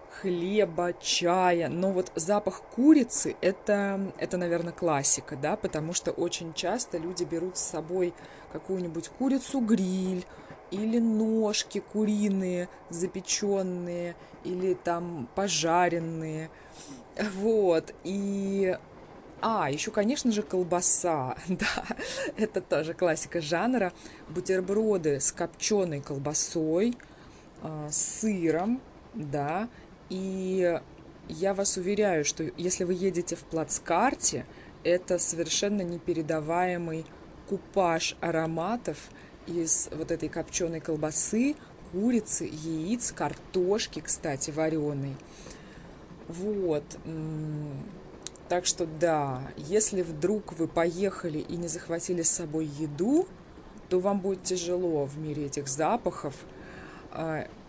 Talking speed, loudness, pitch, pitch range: 100 wpm, -27 LUFS, 175 Hz, 160-195 Hz